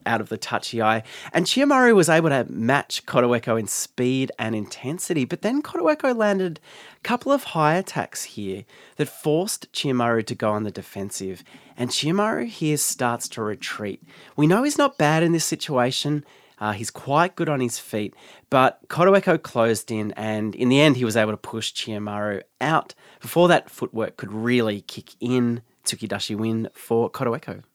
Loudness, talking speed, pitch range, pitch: -22 LUFS, 175 wpm, 110-165 Hz, 125 Hz